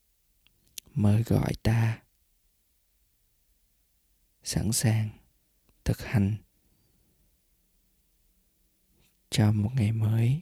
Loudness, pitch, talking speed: -28 LUFS, 105 Hz, 65 wpm